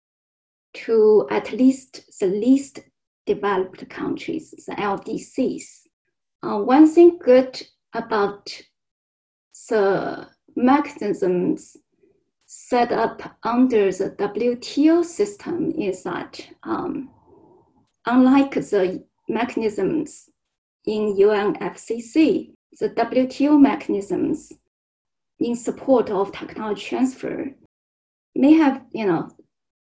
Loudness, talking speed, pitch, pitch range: -21 LUFS, 85 wpm, 270 Hz, 215-330 Hz